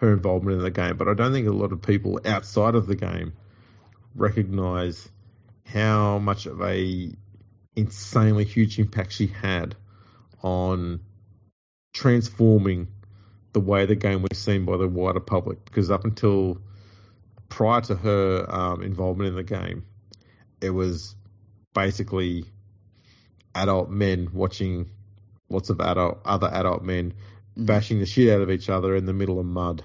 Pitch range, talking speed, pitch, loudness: 95-105 Hz, 150 wpm, 100 Hz, -24 LUFS